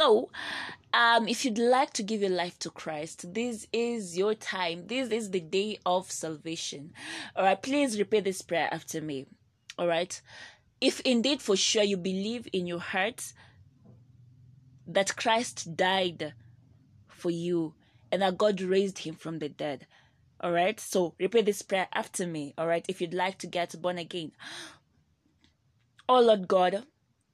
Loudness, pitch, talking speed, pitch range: -29 LUFS, 180 Hz, 160 wpm, 160-210 Hz